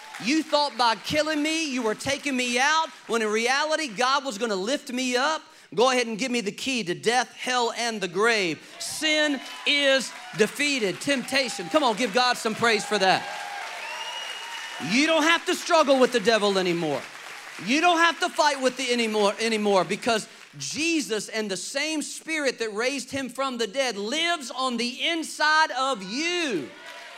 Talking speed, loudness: 180 wpm, -24 LUFS